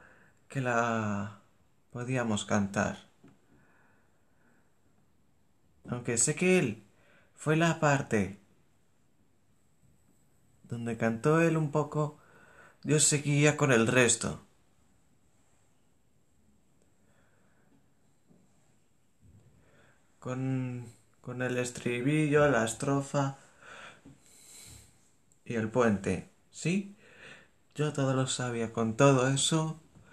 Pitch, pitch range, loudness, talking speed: 125 Hz, 115-150 Hz, -29 LUFS, 75 wpm